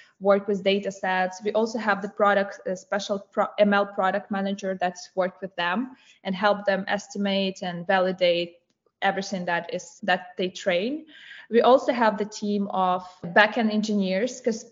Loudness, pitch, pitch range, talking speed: -25 LUFS, 200 Hz, 185-210 Hz, 165 wpm